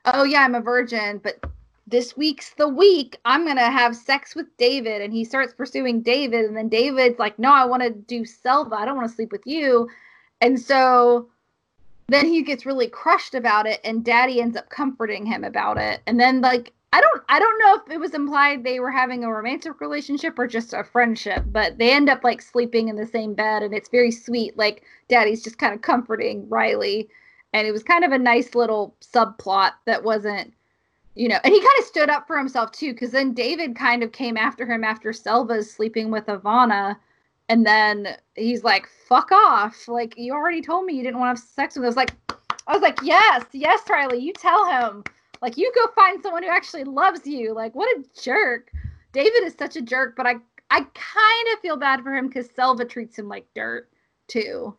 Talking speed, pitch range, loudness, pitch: 215 wpm, 225-285 Hz, -20 LUFS, 245 Hz